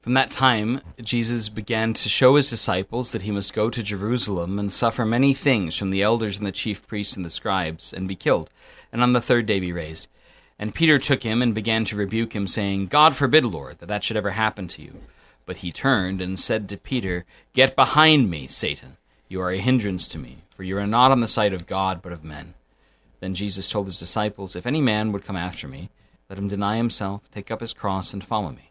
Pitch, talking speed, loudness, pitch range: 105 Hz, 230 wpm, -22 LUFS, 95-120 Hz